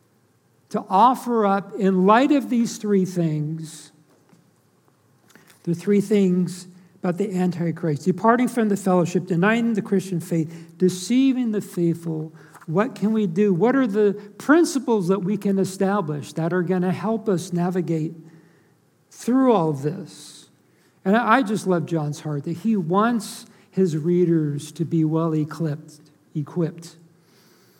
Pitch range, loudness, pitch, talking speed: 165-210 Hz, -22 LUFS, 185 Hz, 140 wpm